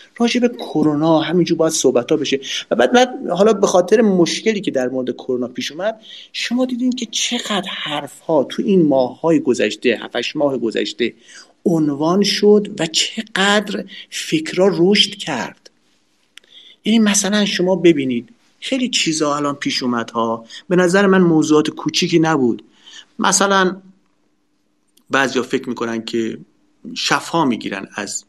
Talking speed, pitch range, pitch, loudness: 140 wpm, 145-205 Hz, 175 Hz, -17 LUFS